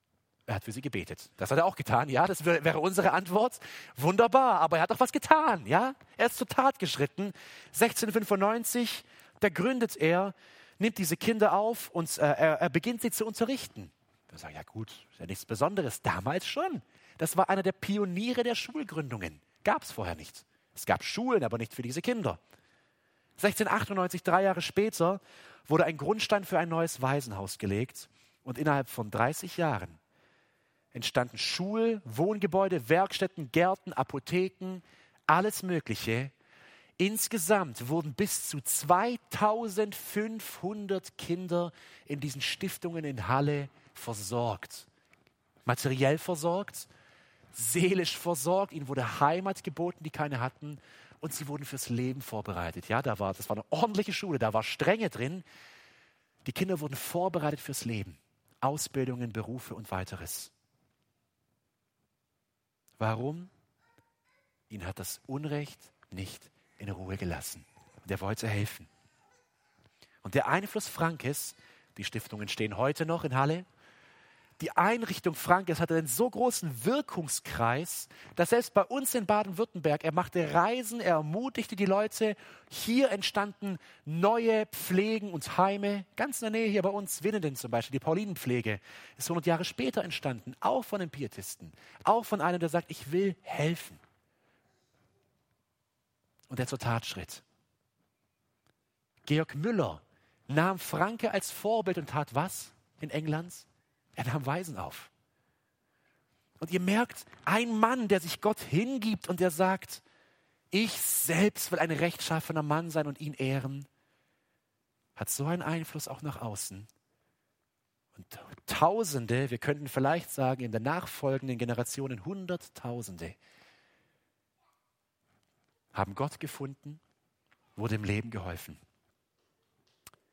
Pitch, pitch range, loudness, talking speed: 160 Hz, 125-195 Hz, -31 LUFS, 135 wpm